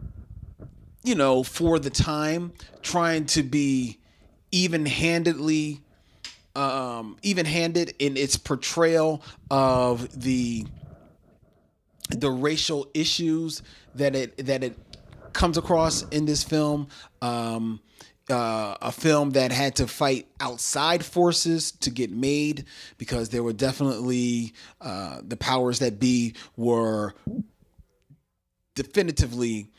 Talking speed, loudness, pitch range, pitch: 105 wpm, -25 LUFS, 120-155 Hz, 135 Hz